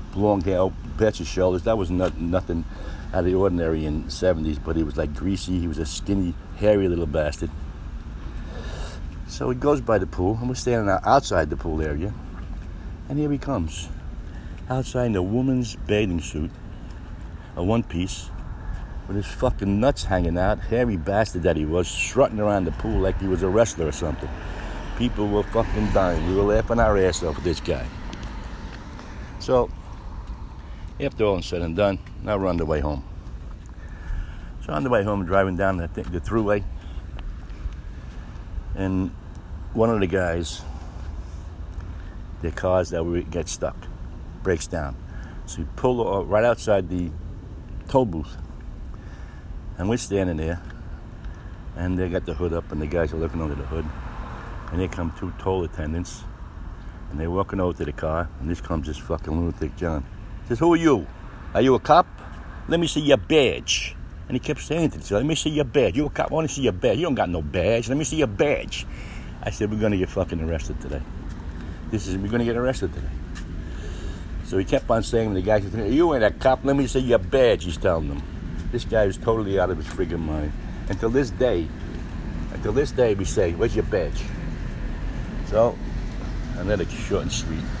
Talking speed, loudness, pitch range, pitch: 190 wpm, -24 LUFS, 80-105 Hz, 90 Hz